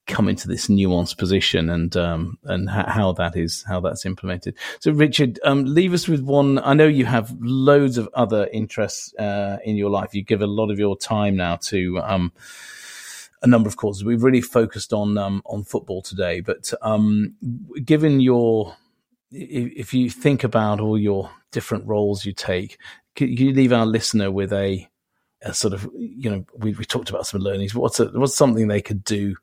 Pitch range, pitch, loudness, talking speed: 100-125 Hz, 110 Hz, -21 LUFS, 195 wpm